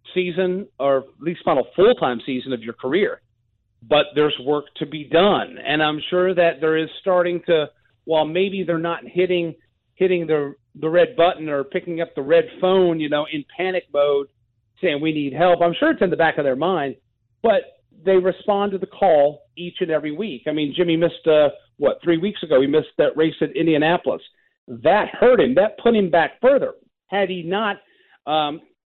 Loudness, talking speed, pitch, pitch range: -20 LUFS, 200 wpm, 165 Hz, 150-185 Hz